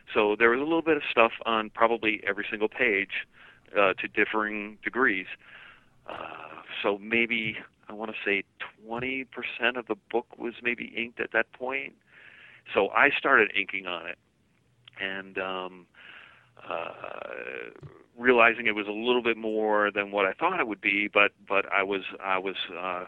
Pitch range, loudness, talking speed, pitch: 100-115 Hz, -26 LUFS, 165 wpm, 110 Hz